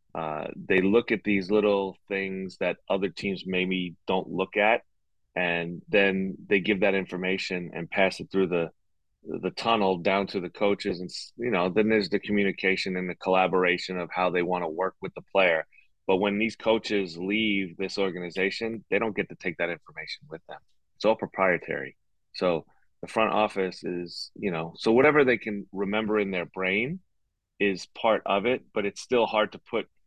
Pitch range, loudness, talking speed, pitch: 90-100 Hz, -27 LUFS, 190 wpm, 95 Hz